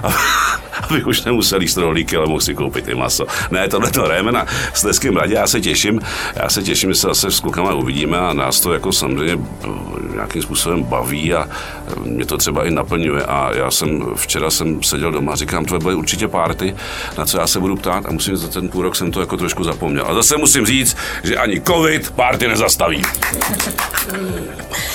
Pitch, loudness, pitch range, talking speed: 90 Hz, -16 LUFS, 80-95 Hz, 195 wpm